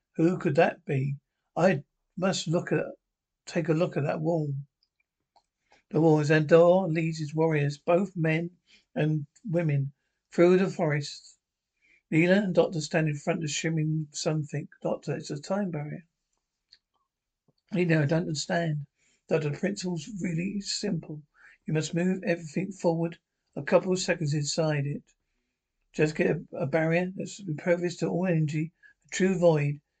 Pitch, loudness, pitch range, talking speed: 165 Hz, -28 LUFS, 155-180 Hz, 155 wpm